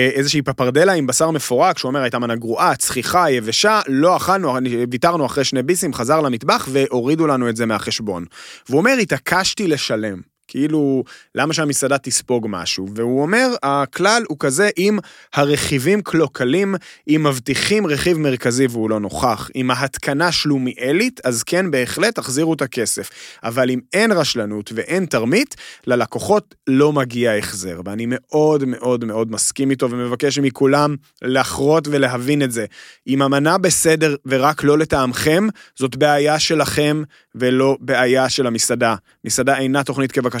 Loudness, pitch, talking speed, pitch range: -17 LUFS, 135 Hz, 145 wpm, 125-155 Hz